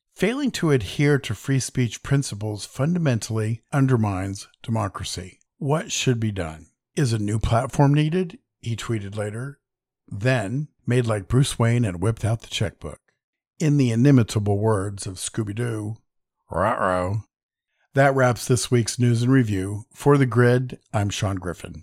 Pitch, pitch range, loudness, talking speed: 115 Hz, 105-130 Hz, -23 LUFS, 145 wpm